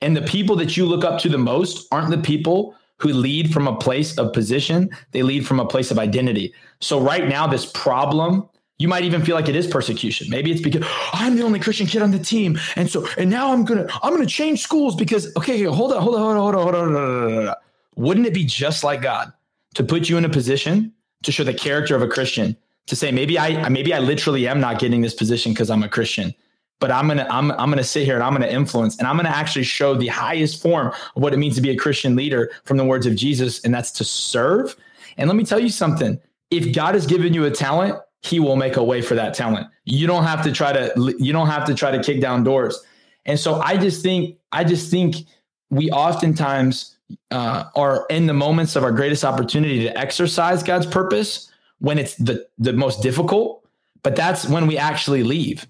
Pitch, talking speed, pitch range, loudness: 150 Hz, 235 wpm, 130-175 Hz, -19 LUFS